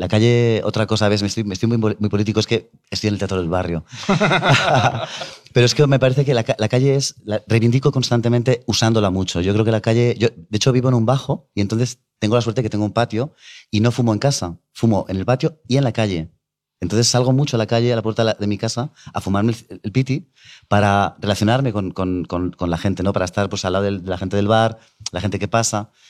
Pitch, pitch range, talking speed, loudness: 110 Hz, 100-120 Hz, 260 wpm, -19 LUFS